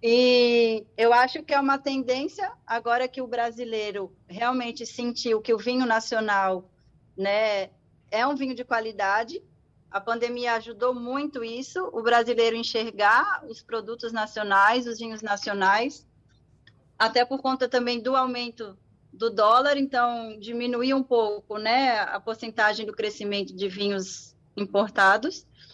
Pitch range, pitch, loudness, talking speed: 215-250 Hz, 230 Hz, -25 LUFS, 135 wpm